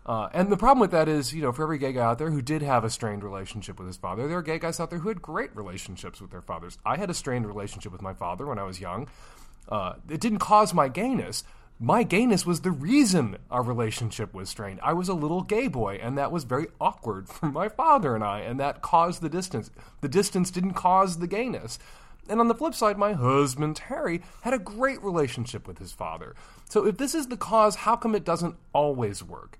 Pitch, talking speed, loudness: 155 Hz, 240 wpm, -26 LUFS